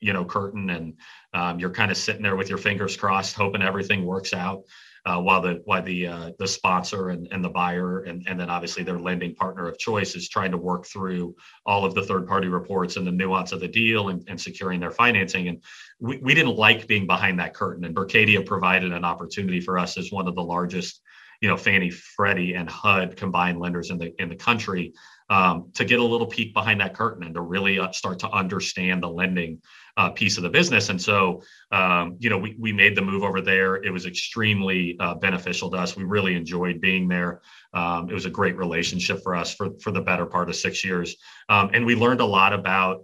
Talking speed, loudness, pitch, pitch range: 230 wpm, -23 LUFS, 95 Hz, 90-100 Hz